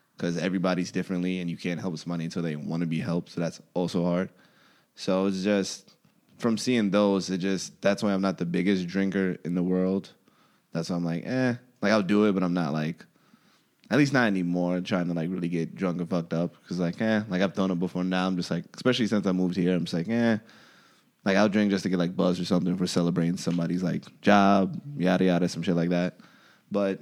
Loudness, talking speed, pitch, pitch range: -27 LUFS, 235 wpm, 90 Hz, 85-100 Hz